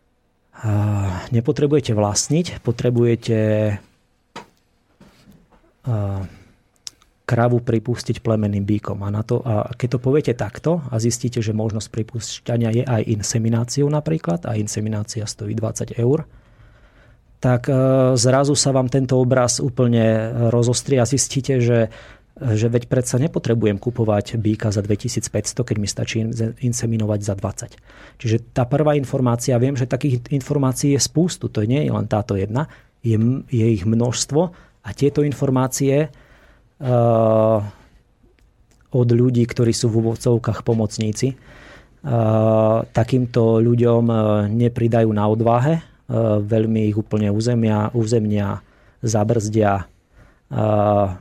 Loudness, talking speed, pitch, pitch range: -19 LUFS, 115 wpm, 115 Hz, 110-125 Hz